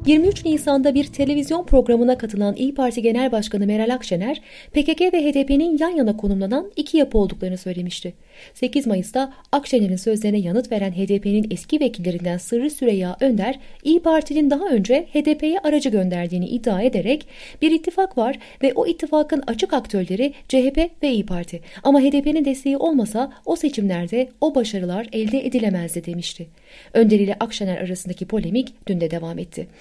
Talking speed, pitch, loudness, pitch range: 150 wpm, 250 Hz, -20 LUFS, 200-285 Hz